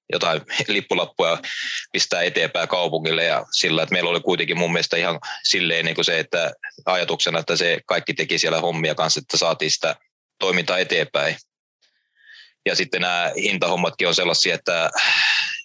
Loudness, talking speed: -20 LUFS, 150 wpm